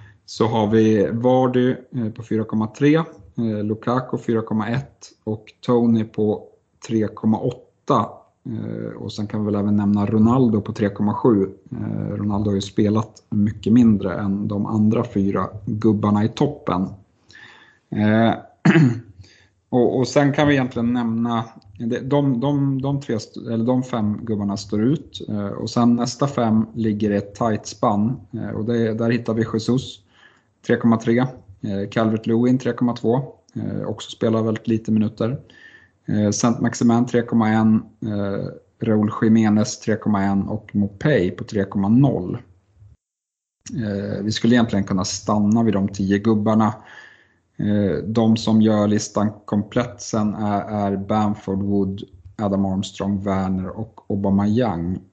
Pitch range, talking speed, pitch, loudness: 100-120 Hz, 125 wpm, 110 Hz, -21 LUFS